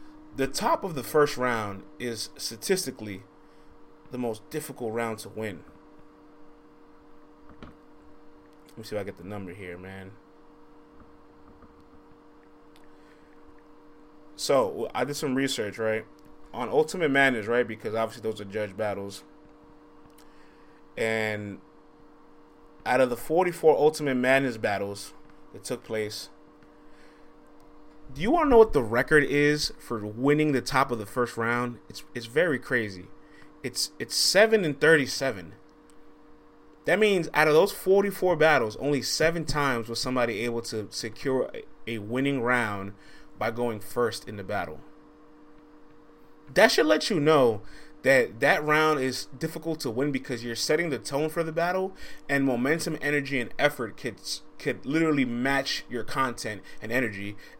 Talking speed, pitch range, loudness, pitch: 140 wpm, 115-155 Hz, -26 LUFS, 145 Hz